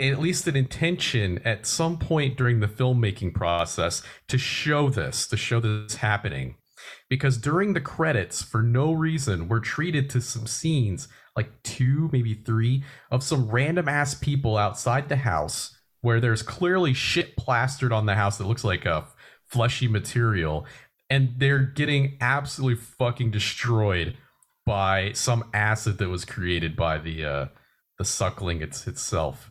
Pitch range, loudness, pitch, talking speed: 105-135 Hz, -25 LUFS, 120 Hz, 155 wpm